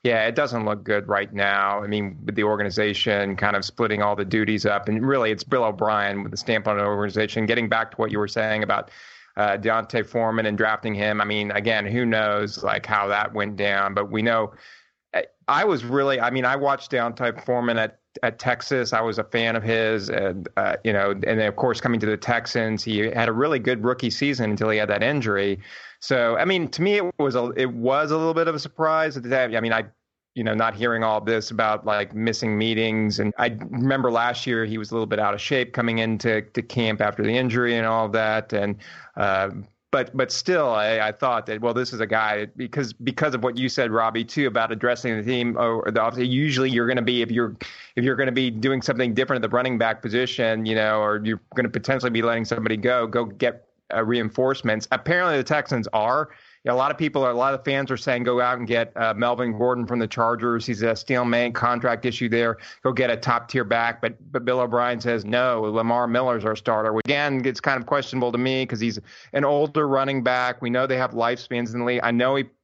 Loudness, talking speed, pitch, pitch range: -23 LUFS, 240 wpm, 115 Hz, 110-125 Hz